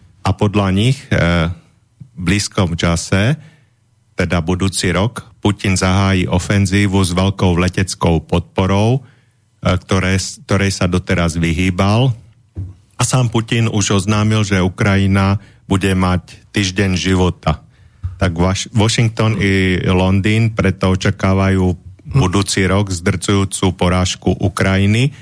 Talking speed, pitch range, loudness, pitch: 110 wpm, 95-110 Hz, -15 LUFS, 95 Hz